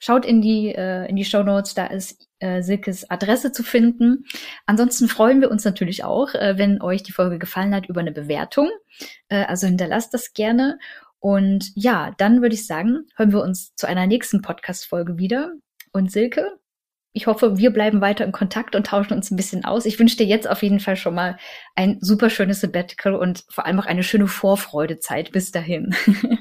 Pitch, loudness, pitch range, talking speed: 200 Hz, -20 LUFS, 185-230 Hz, 200 wpm